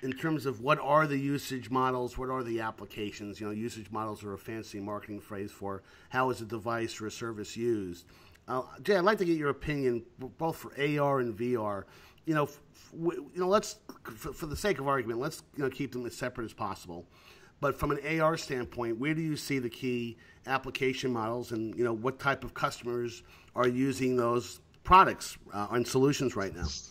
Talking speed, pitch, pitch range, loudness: 210 wpm, 120 Hz, 110-140 Hz, -32 LUFS